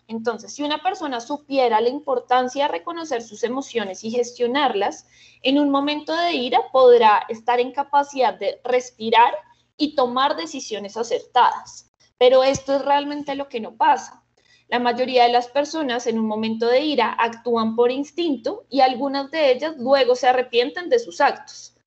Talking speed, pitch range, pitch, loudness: 160 wpm, 240-290 Hz, 260 Hz, -20 LUFS